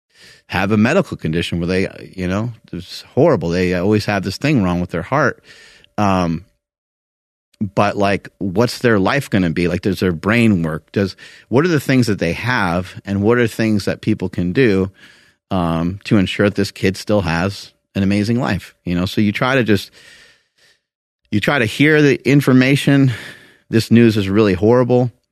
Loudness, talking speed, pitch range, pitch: -16 LUFS, 185 wpm, 90-115 Hz, 100 Hz